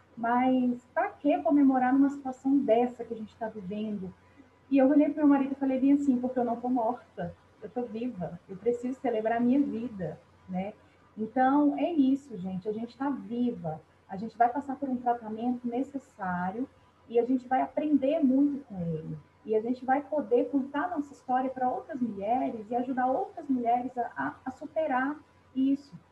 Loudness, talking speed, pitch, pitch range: -29 LUFS, 185 wpm, 250 Hz, 230-275 Hz